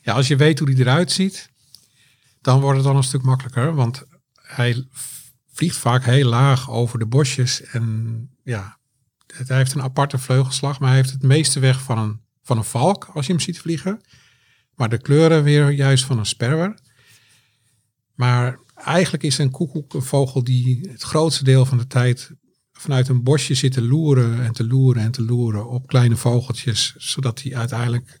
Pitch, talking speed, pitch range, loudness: 130 Hz, 185 wpm, 120-140 Hz, -19 LUFS